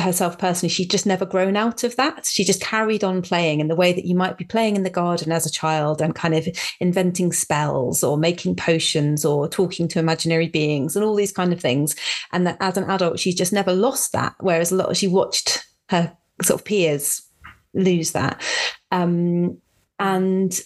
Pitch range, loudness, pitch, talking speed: 165-190 Hz, -20 LUFS, 180 Hz, 205 wpm